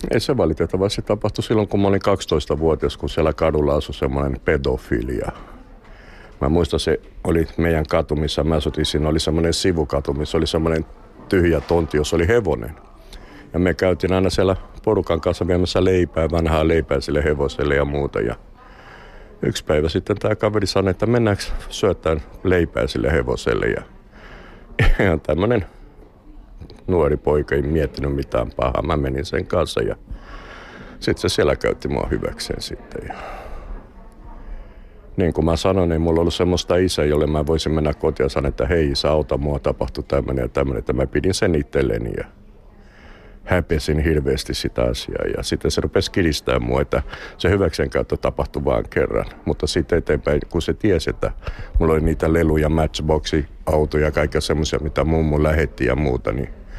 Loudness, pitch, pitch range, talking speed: -20 LUFS, 80 Hz, 75-90 Hz, 165 wpm